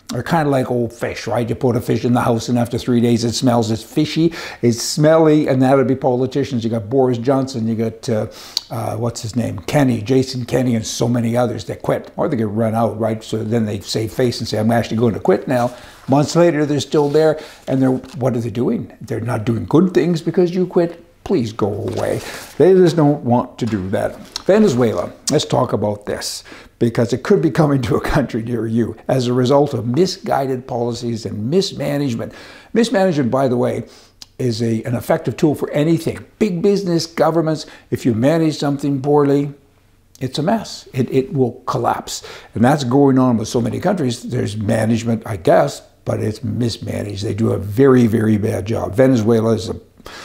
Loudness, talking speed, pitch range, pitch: -17 LUFS, 205 wpm, 115-140 Hz, 125 Hz